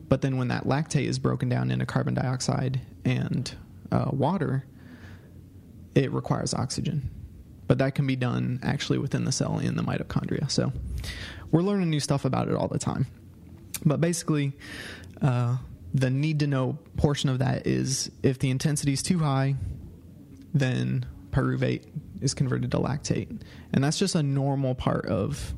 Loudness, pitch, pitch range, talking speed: -27 LUFS, 130 Hz, 90-140 Hz, 160 wpm